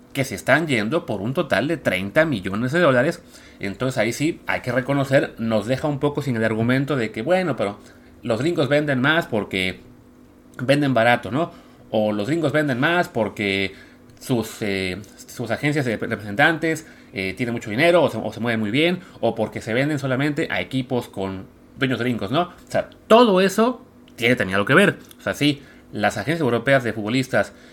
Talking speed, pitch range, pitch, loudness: 190 wpm, 110-150 Hz, 125 Hz, -21 LUFS